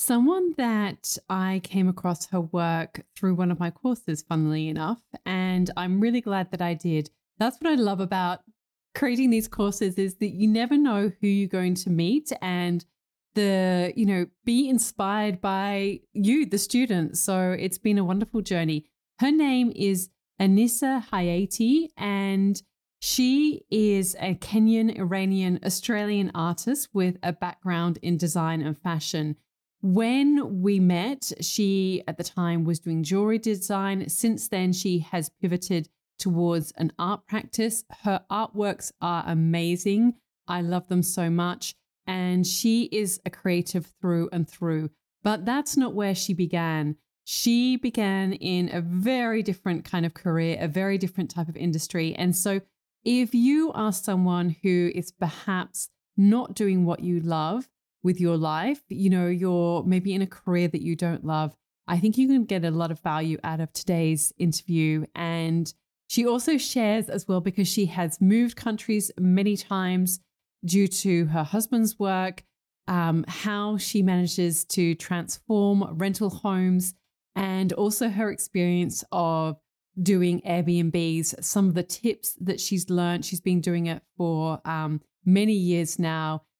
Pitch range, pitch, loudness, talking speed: 170-210 Hz, 185 Hz, -25 LUFS, 155 wpm